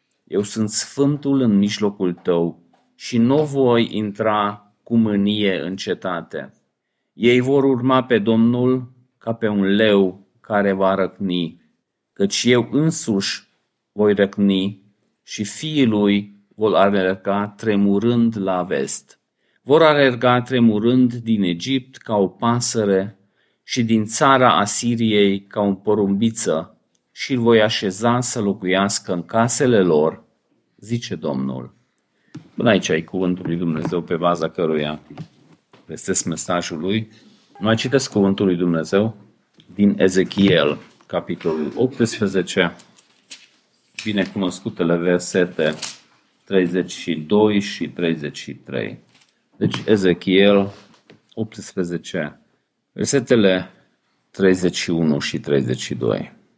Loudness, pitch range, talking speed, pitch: -19 LUFS, 95-115 Hz, 105 wpm, 100 Hz